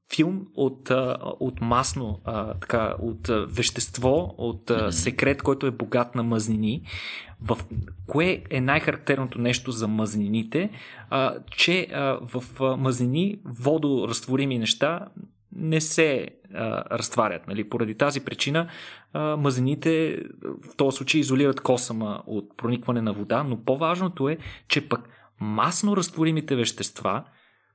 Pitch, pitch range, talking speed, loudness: 130 Hz, 115-145 Hz, 110 wpm, -24 LUFS